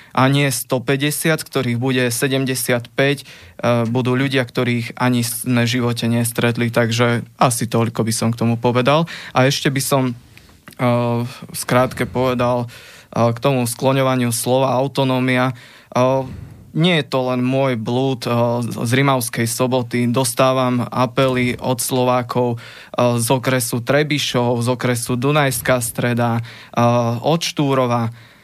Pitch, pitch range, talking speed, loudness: 125 Hz, 120-135 Hz, 130 wpm, -18 LUFS